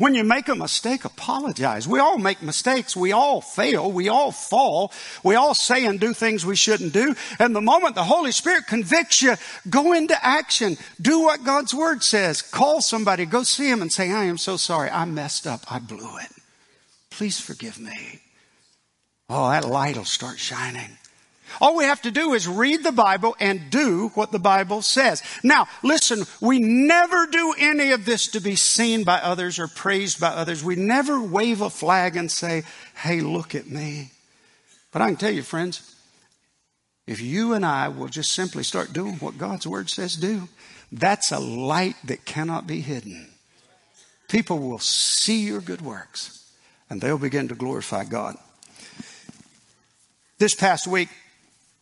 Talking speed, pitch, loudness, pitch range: 175 wpm, 200 Hz, -21 LUFS, 165-245 Hz